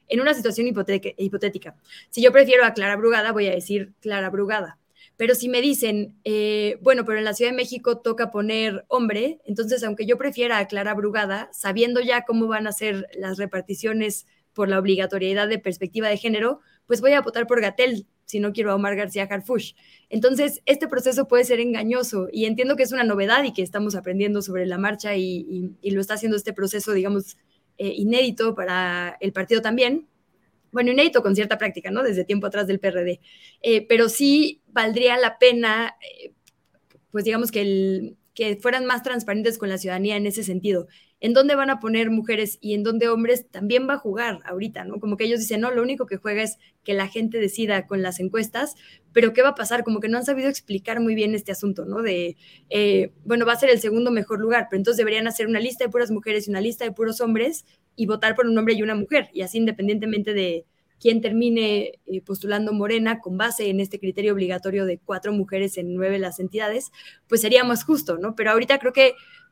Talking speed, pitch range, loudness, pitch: 210 wpm, 200-240 Hz, -22 LUFS, 215 Hz